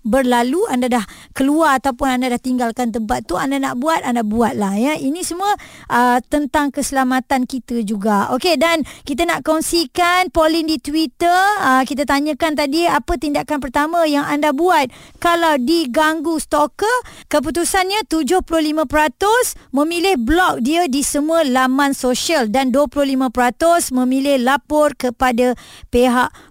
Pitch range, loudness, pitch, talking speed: 255-325 Hz, -17 LUFS, 290 Hz, 135 wpm